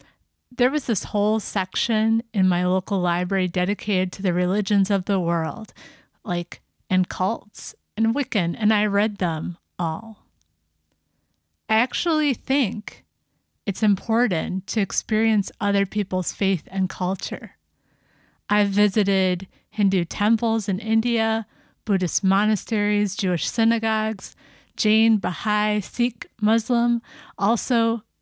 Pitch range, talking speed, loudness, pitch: 185-220 Hz, 115 wpm, -22 LUFS, 205 Hz